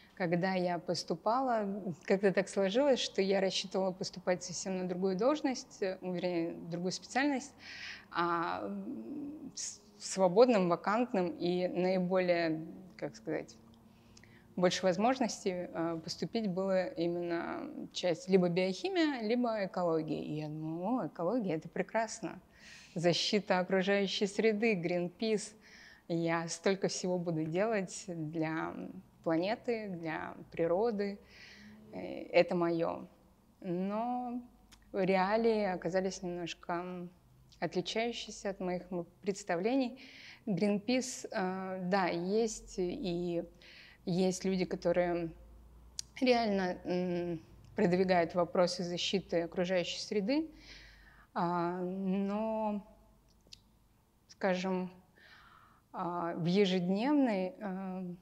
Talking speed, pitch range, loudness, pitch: 80 wpm, 175-210 Hz, -34 LUFS, 185 Hz